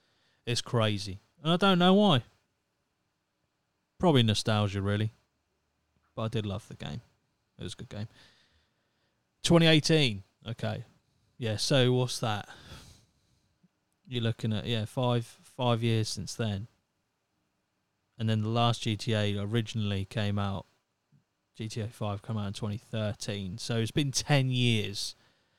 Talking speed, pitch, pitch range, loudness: 130 wpm, 110 Hz, 105-120 Hz, -29 LUFS